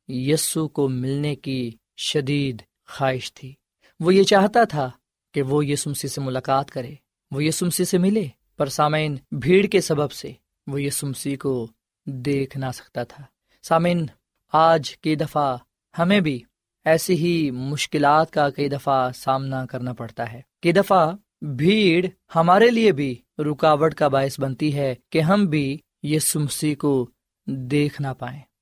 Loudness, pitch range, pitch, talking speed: -21 LUFS, 135-160 Hz, 145 Hz, 145 wpm